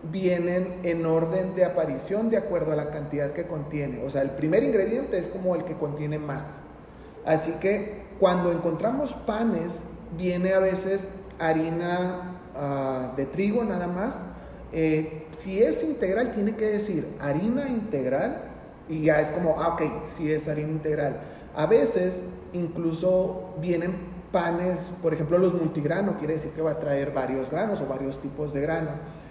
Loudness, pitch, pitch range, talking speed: -27 LUFS, 165 Hz, 150-185 Hz, 160 wpm